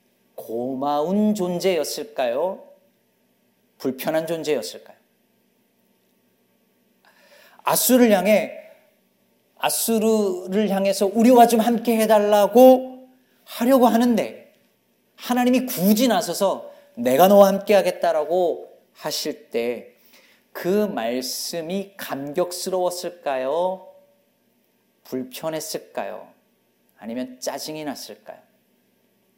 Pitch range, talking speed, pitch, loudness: 175-235 Hz, 200 characters per minute, 200 Hz, -20 LUFS